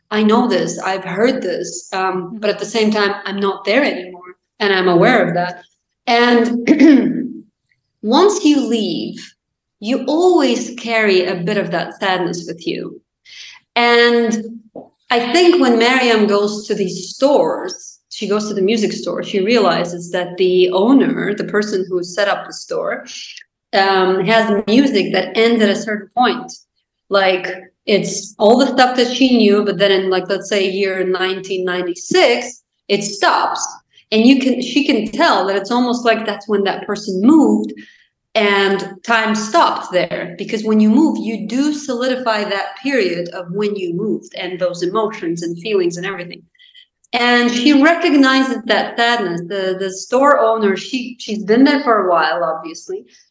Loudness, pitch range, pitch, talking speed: -15 LUFS, 190-245 Hz, 210 Hz, 165 wpm